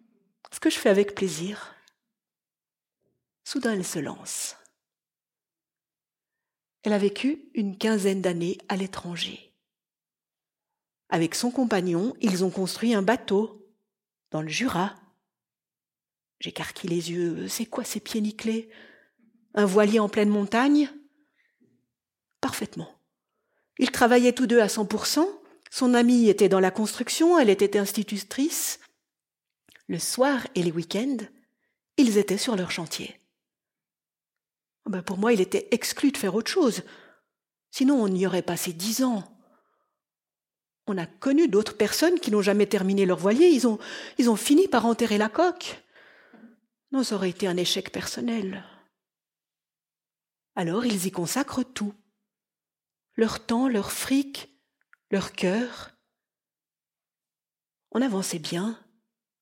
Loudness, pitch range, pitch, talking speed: -25 LUFS, 195-250 Hz, 215 Hz, 125 wpm